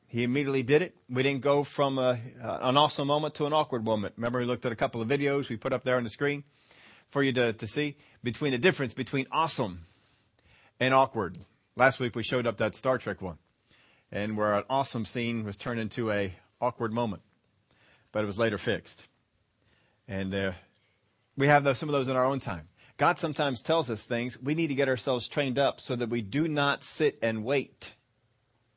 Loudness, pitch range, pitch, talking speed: -29 LUFS, 110-140 Hz, 125 Hz, 205 wpm